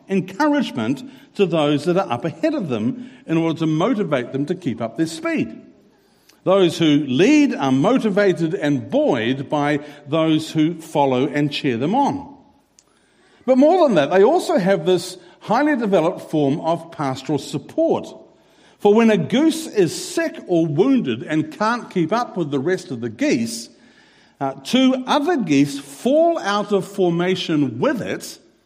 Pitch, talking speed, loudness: 185 Hz, 160 wpm, -19 LUFS